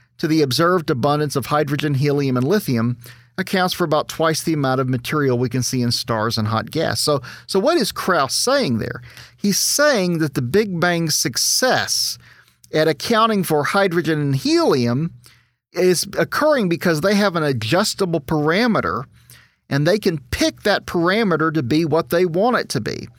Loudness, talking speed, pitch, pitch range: -18 LUFS, 175 wpm, 160 Hz, 130-180 Hz